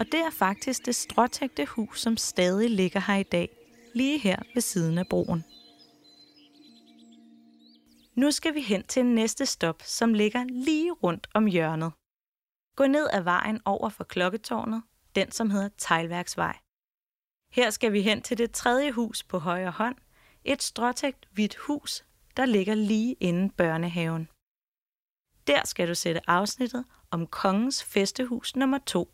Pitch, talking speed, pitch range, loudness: 215 Hz, 150 wpm, 180-250 Hz, -27 LUFS